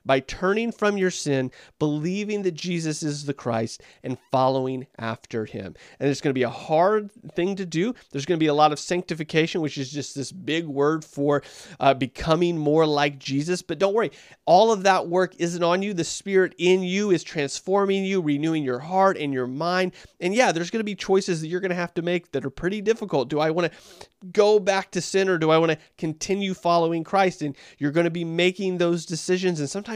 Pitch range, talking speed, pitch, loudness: 145-185 Hz, 225 wpm, 170 Hz, -24 LUFS